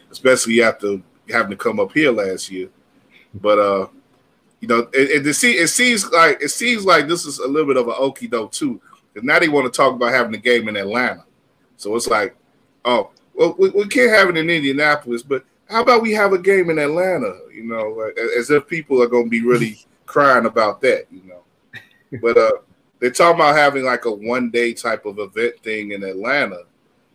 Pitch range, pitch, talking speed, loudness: 115-185 Hz, 135 Hz, 210 wpm, -17 LUFS